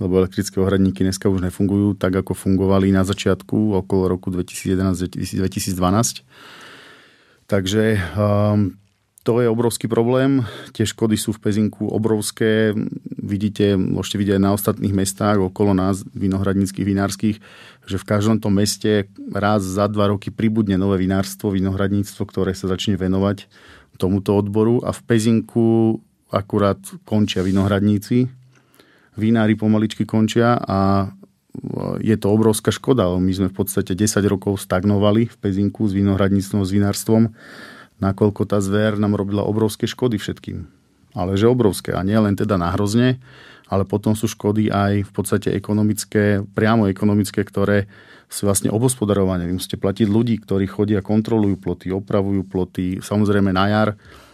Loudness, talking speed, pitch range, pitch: -19 LUFS, 140 wpm, 95-110 Hz, 100 Hz